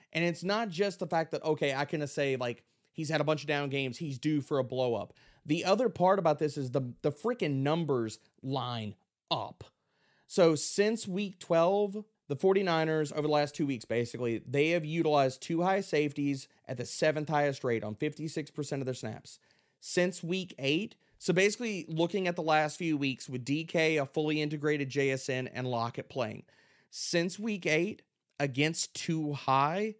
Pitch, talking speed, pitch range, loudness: 150 Hz, 180 wpm, 135-170 Hz, -31 LUFS